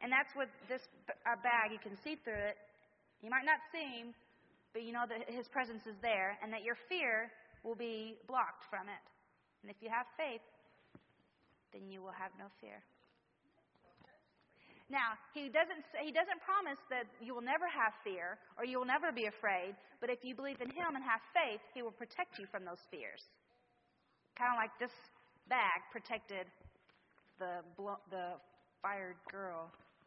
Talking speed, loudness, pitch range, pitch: 175 wpm, -40 LUFS, 205-255 Hz, 230 Hz